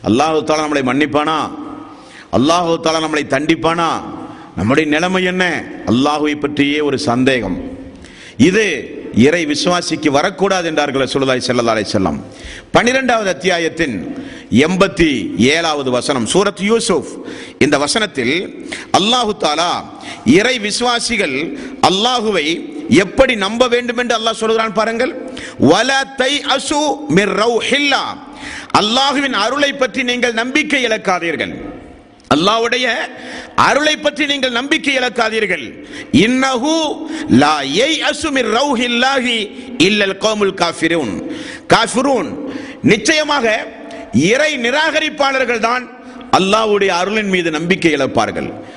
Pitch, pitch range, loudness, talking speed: 235 Hz, 175-270 Hz, -14 LUFS, 85 wpm